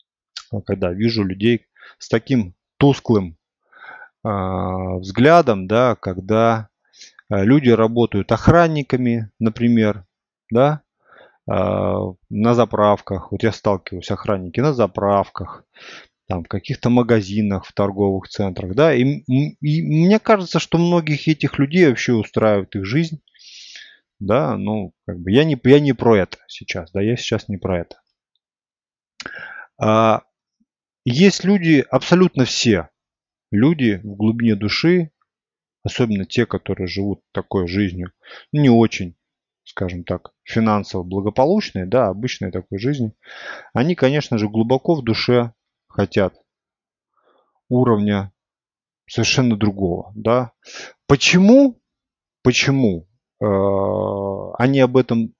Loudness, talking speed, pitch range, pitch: -18 LUFS, 110 wpm, 100-130 Hz, 115 Hz